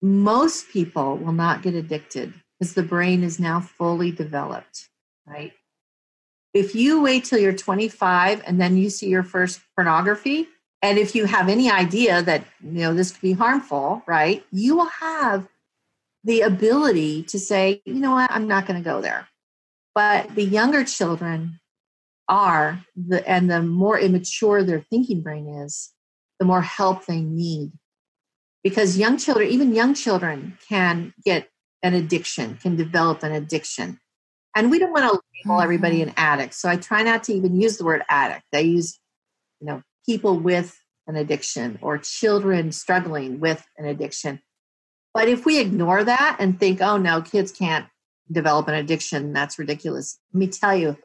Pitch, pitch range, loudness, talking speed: 185 Hz, 165-210 Hz, -21 LUFS, 170 wpm